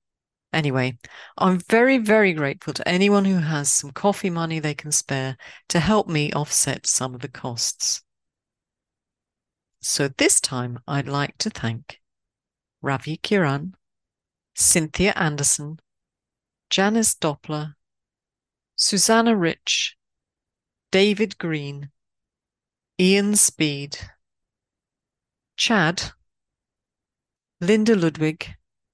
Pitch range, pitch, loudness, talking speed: 135-190 Hz, 150 Hz, -21 LUFS, 95 wpm